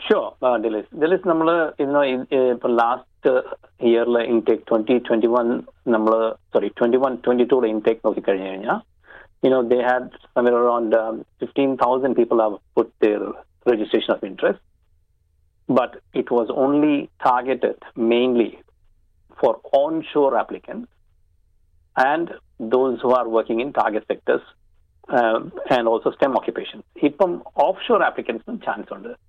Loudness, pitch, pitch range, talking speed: -20 LUFS, 120 Hz, 110-130 Hz, 145 wpm